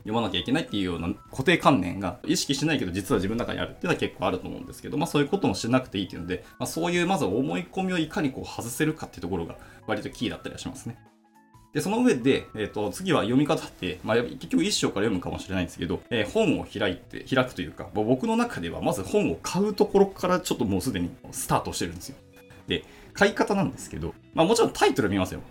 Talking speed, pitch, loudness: 540 characters per minute, 130 Hz, -26 LUFS